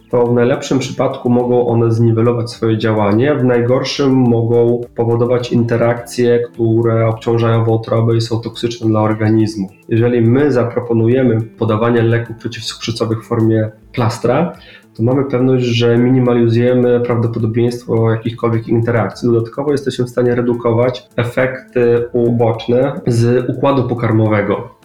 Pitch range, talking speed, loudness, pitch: 115-120 Hz, 120 wpm, -14 LUFS, 120 Hz